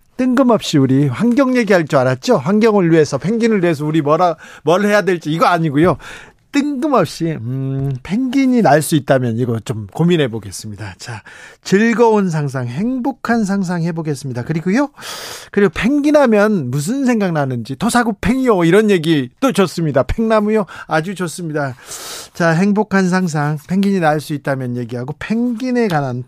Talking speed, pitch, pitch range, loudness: 340 characters per minute, 175 Hz, 145-220 Hz, -15 LUFS